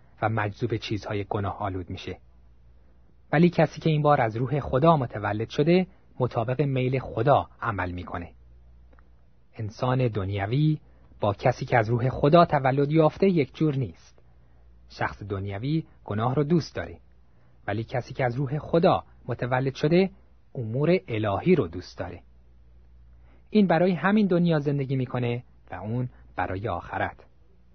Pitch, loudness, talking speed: 115 Hz, -25 LUFS, 135 wpm